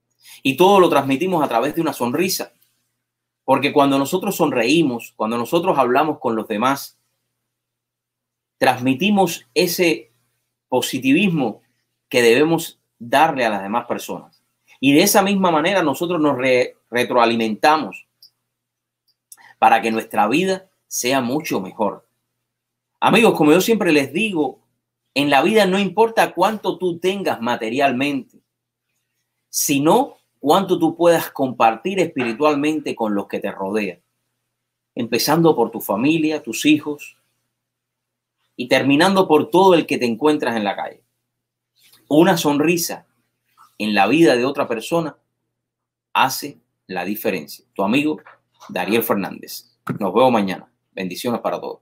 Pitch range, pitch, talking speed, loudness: 120-175 Hz, 150 Hz, 125 wpm, -18 LUFS